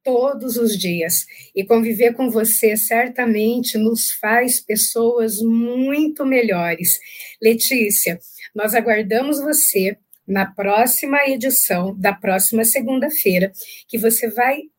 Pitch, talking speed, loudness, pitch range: 230 Hz, 105 wpm, -17 LUFS, 205-250 Hz